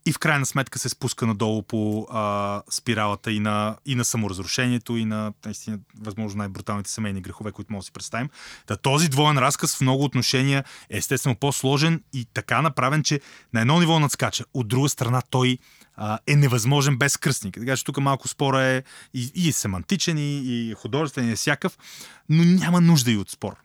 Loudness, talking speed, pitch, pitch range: -23 LUFS, 190 wpm, 125 Hz, 110-140 Hz